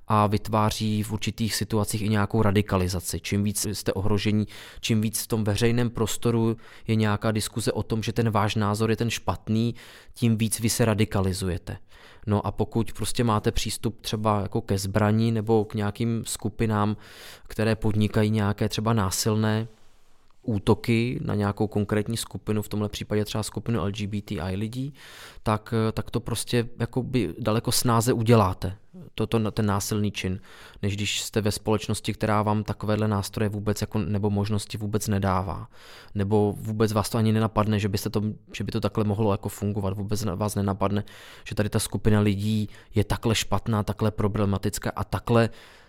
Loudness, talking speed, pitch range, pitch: -26 LUFS, 160 wpm, 105-110 Hz, 105 Hz